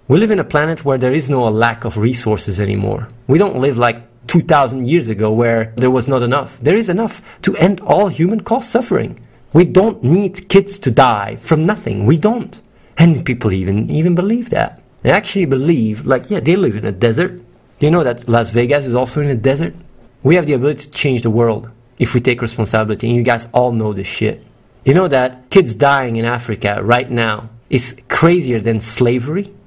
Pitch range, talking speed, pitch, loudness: 115-170 Hz, 205 wpm, 130 Hz, -15 LUFS